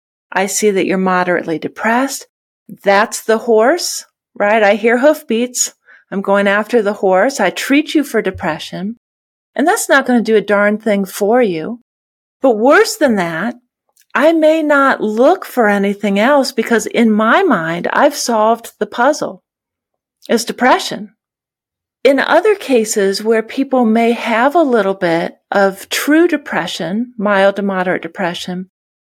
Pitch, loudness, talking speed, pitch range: 225 Hz, -14 LUFS, 150 wpm, 200-265 Hz